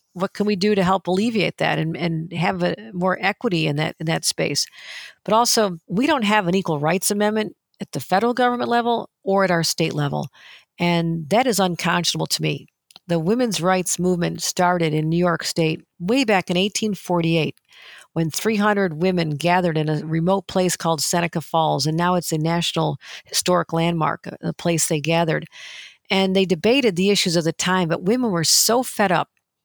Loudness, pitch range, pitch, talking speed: -20 LUFS, 165-200 Hz, 180 Hz, 195 wpm